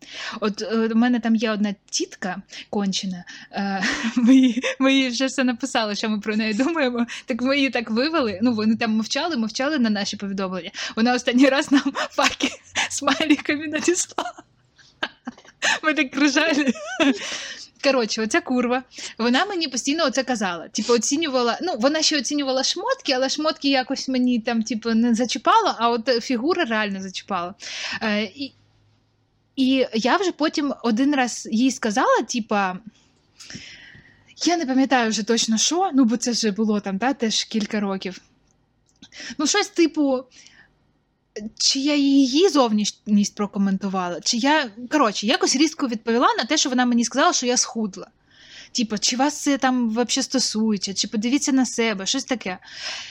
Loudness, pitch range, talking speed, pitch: -21 LUFS, 220-275 Hz, 145 wpm, 250 Hz